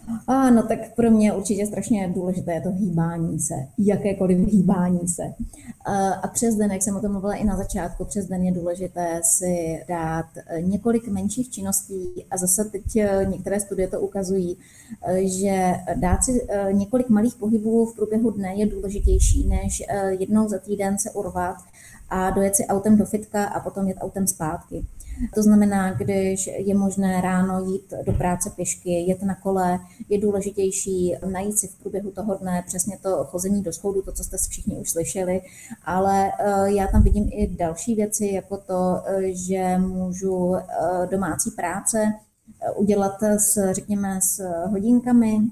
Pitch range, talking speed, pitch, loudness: 185-205 Hz, 155 wpm, 195 Hz, -23 LUFS